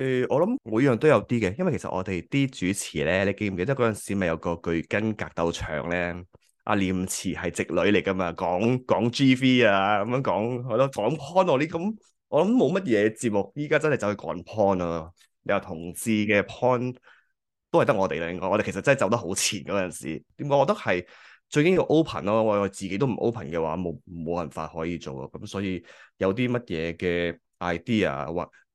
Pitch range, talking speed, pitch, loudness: 90-125 Hz, 330 characters per minute, 100 Hz, -25 LUFS